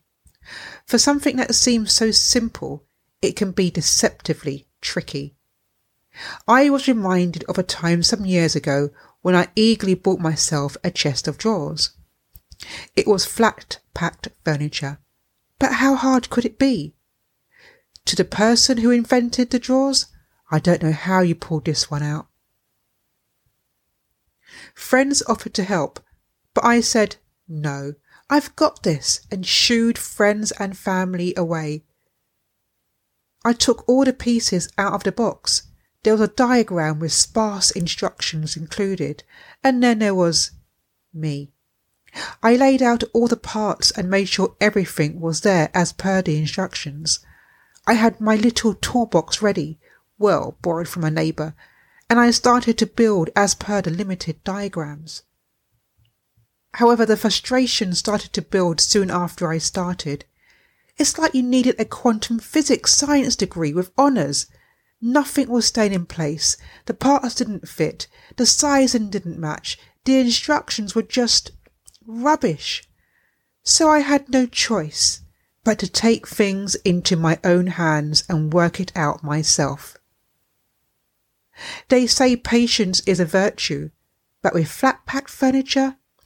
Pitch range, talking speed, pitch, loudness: 160-235 Hz, 140 wpm, 195 Hz, -19 LUFS